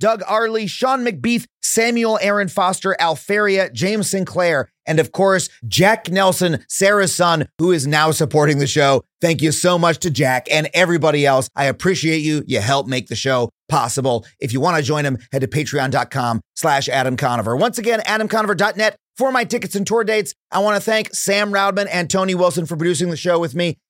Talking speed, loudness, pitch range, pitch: 195 wpm, -17 LUFS, 150-205 Hz, 175 Hz